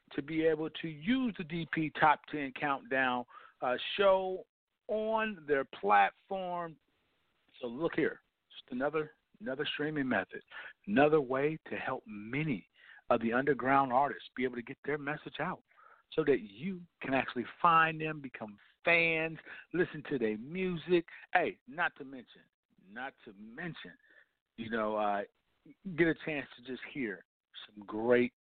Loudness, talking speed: -33 LUFS, 150 wpm